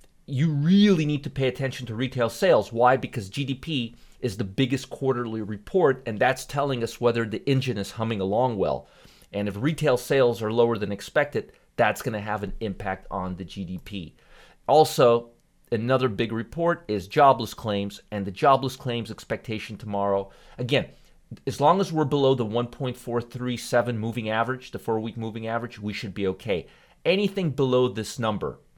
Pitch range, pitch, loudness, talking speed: 105-135 Hz, 120 Hz, -25 LUFS, 170 wpm